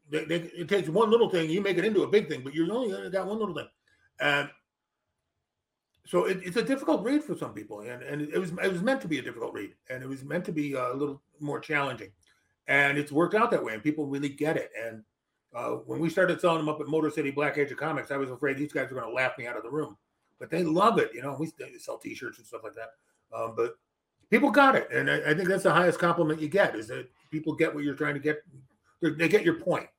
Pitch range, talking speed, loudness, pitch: 145-195 Hz, 270 wpm, -28 LUFS, 160 Hz